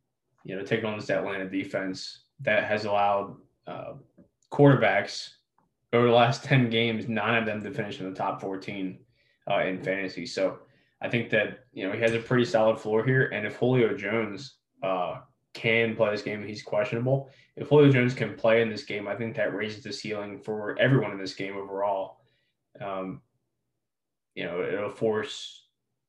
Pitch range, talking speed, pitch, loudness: 100-115 Hz, 180 wpm, 110 Hz, -27 LUFS